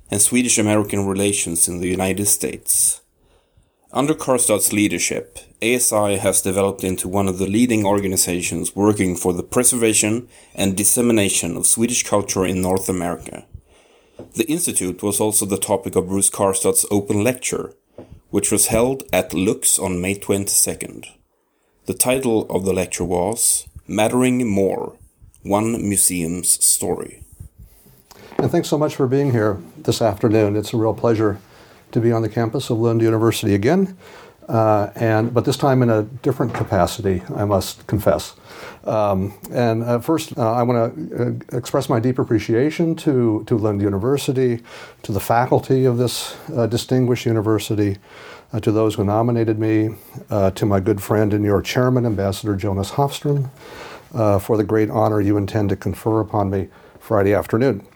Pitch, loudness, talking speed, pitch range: 110 Hz, -18 LUFS, 155 wpm, 100-120 Hz